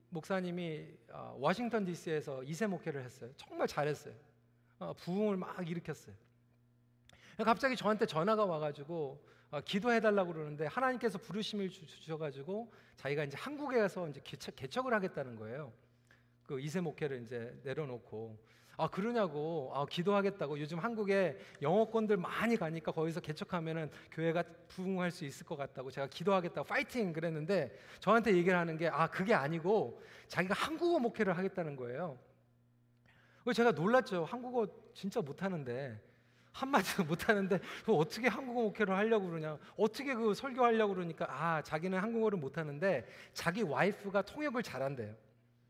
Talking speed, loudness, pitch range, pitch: 360 characters per minute, -36 LUFS, 145-210 Hz, 175 Hz